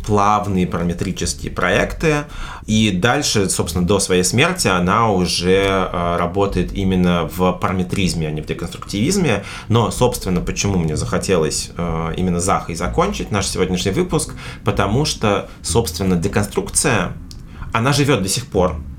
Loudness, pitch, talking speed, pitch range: -18 LUFS, 95 Hz, 125 wpm, 85-105 Hz